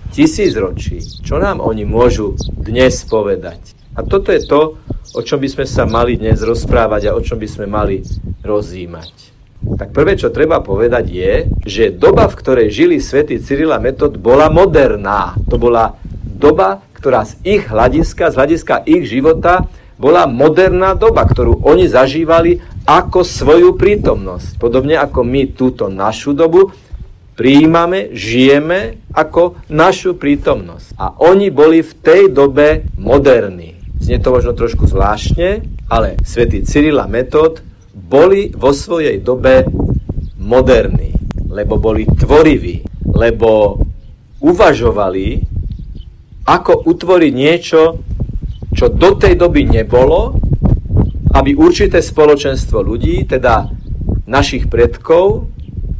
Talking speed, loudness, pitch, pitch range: 125 wpm, -11 LUFS, 125 Hz, 100-165 Hz